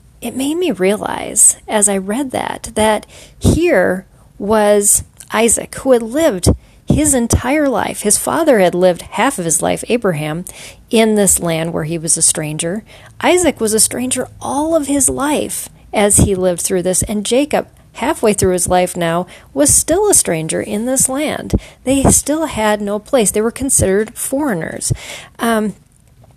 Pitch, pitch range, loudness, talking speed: 215 Hz, 185-270 Hz, -14 LUFS, 165 wpm